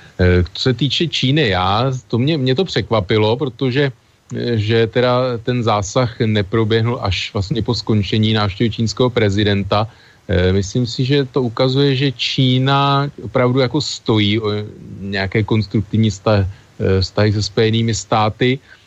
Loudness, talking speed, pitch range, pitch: -17 LUFS, 125 wpm, 105-130 Hz, 115 Hz